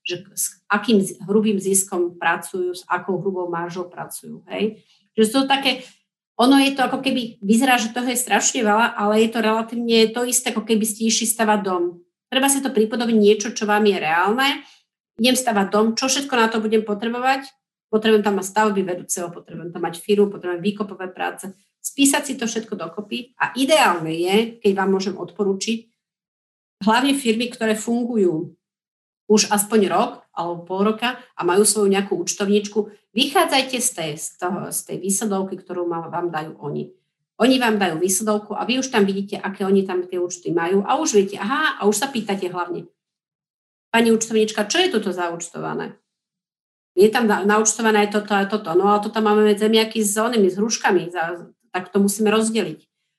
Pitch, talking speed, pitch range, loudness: 210 Hz, 180 wpm, 185-225 Hz, -20 LUFS